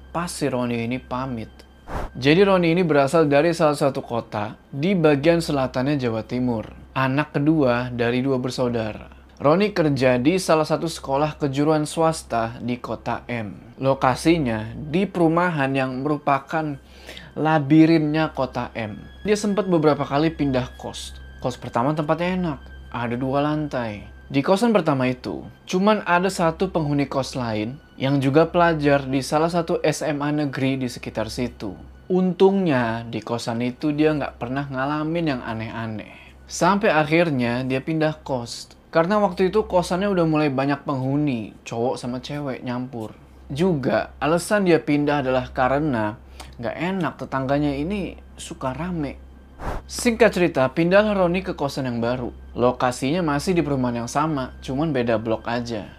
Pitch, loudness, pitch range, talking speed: 140 Hz, -22 LUFS, 120-160 Hz, 140 wpm